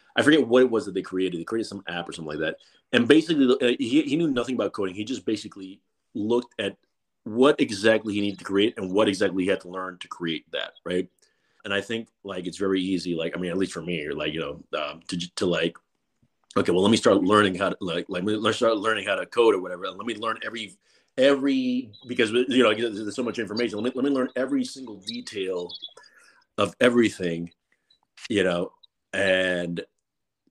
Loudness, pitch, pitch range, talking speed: -25 LUFS, 110 Hz, 95-125 Hz, 220 wpm